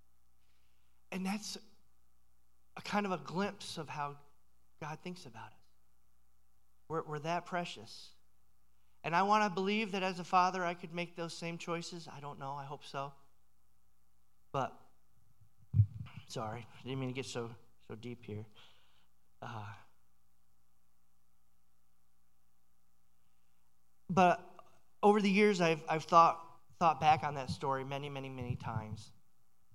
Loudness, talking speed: -35 LUFS, 135 wpm